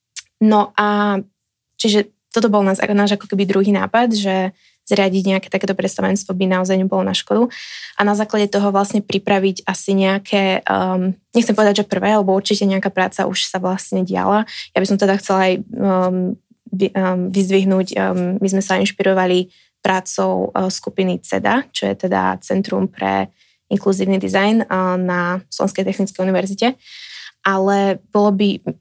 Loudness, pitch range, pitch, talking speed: -17 LUFS, 185-205 Hz, 195 Hz, 155 wpm